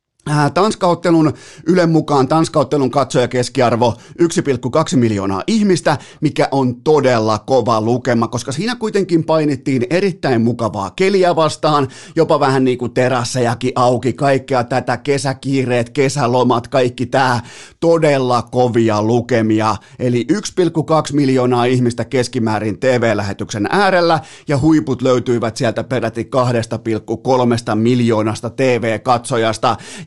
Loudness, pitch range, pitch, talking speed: -15 LUFS, 120-150 Hz, 130 Hz, 105 wpm